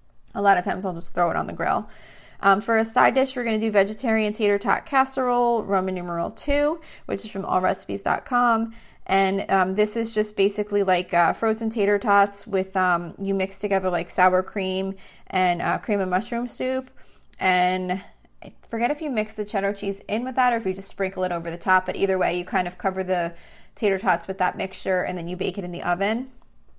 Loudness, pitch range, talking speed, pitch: -23 LUFS, 185-220 Hz, 215 wpm, 195 Hz